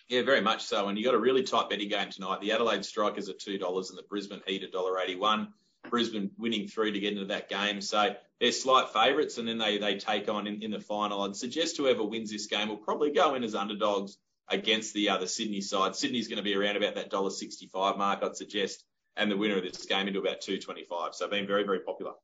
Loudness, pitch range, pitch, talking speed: -30 LUFS, 100-110 Hz, 105 Hz, 260 wpm